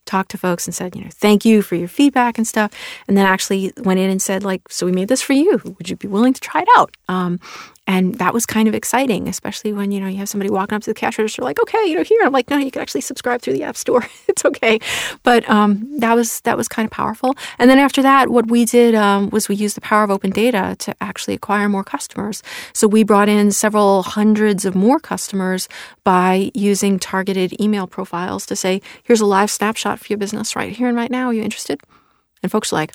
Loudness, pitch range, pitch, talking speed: -17 LUFS, 195-240 Hz, 210 Hz, 255 wpm